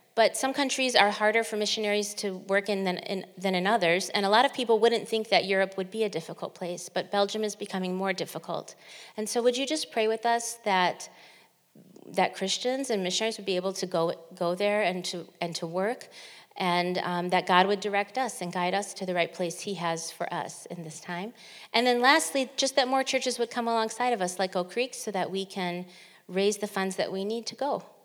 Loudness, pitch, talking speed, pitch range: -28 LUFS, 200 Hz, 230 wpm, 180-230 Hz